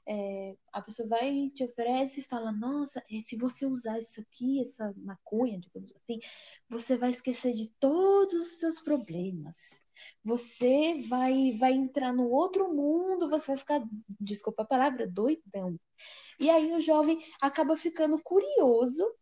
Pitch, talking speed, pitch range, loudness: 255 Hz, 145 wpm, 225-300 Hz, -30 LUFS